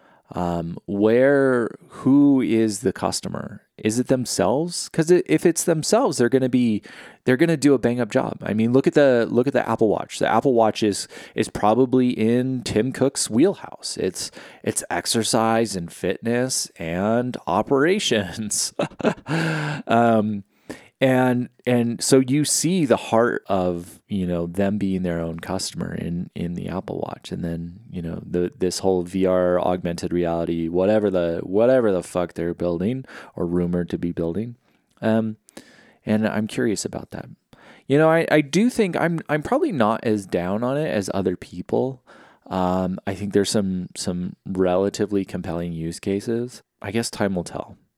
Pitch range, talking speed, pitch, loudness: 90-130 Hz, 165 wpm, 110 Hz, -22 LUFS